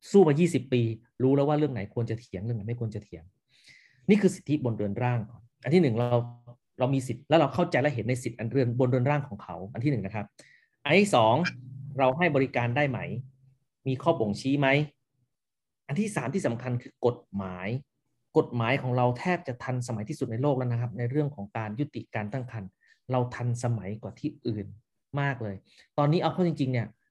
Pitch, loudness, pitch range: 125 Hz, -28 LUFS, 115-140 Hz